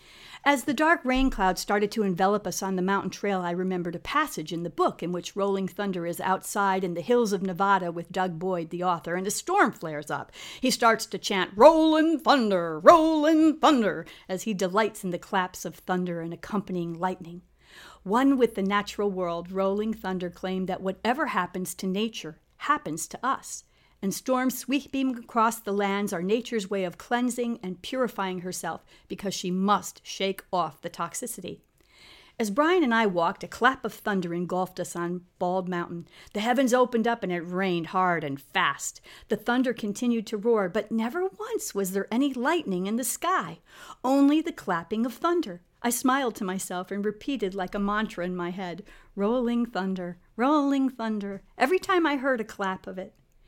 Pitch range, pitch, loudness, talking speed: 180-245 Hz, 200 Hz, -26 LUFS, 185 wpm